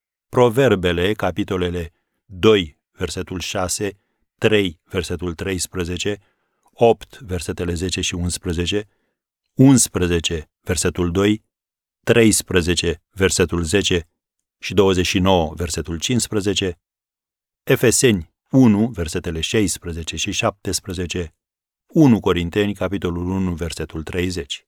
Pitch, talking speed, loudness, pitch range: 90 Hz, 85 wpm, -19 LUFS, 85-100 Hz